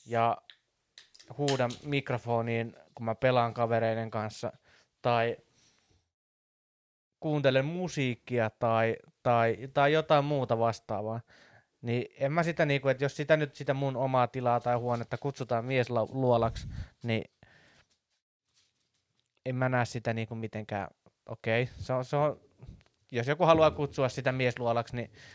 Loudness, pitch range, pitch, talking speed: -30 LUFS, 115-135 Hz, 120 Hz, 125 wpm